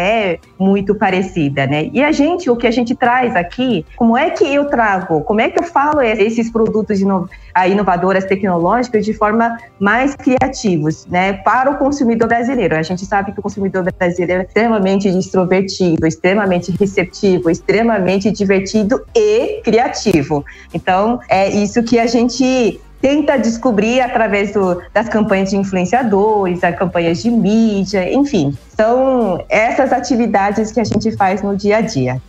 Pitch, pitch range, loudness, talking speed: 205 Hz, 185-240 Hz, -14 LUFS, 155 wpm